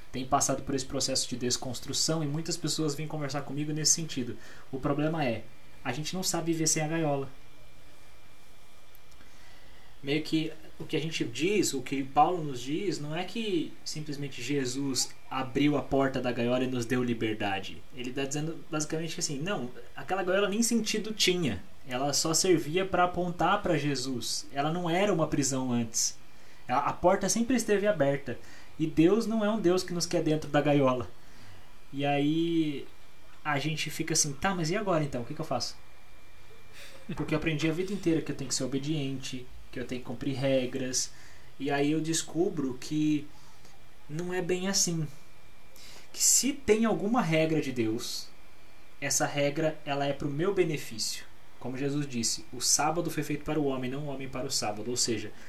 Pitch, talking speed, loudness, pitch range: 145 Hz, 185 wpm, -30 LUFS, 130-165 Hz